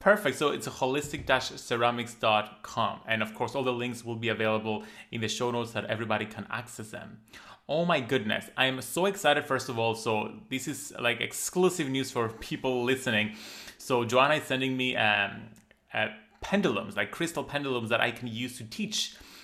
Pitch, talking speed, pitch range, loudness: 120 Hz, 180 wpm, 110-135 Hz, -29 LUFS